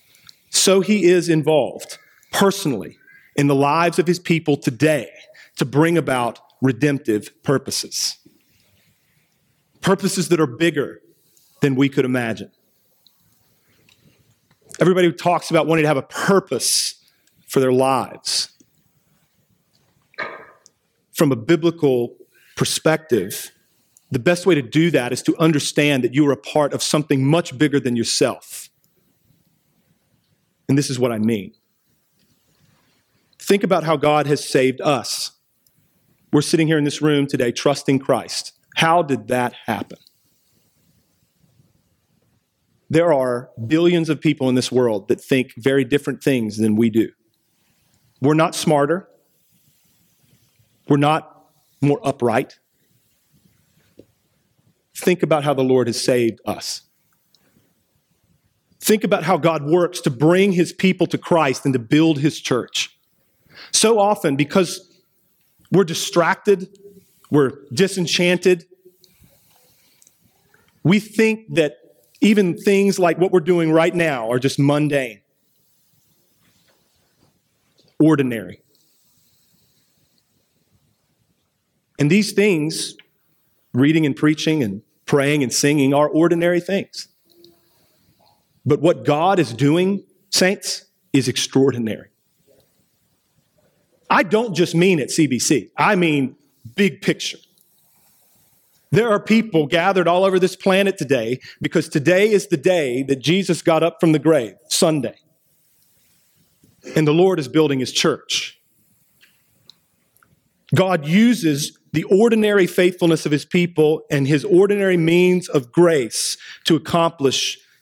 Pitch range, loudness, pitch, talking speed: 140-180 Hz, -18 LUFS, 155 Hz, 120 wpm